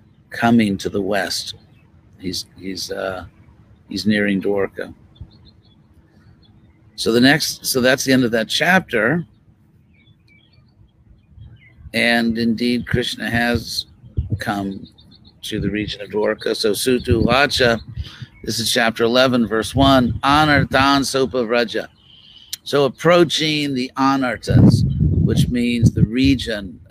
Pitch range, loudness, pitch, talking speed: 105-130 Hz, -17 LUFS, 115 Hz, 110 wpm